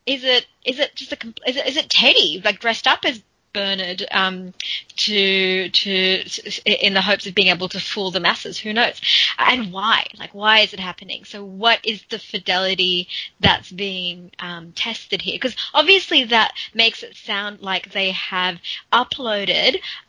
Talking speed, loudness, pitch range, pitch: 175 wpm, -18 LUFS, 190-230 Hz, 205 Hz